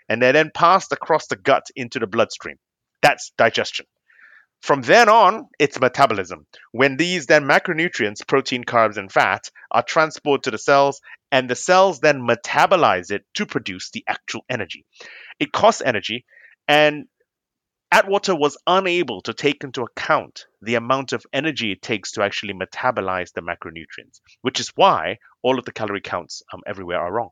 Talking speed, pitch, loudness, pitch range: 165 wpm, 140 Hz, -19 LUFS, 120-160 Hz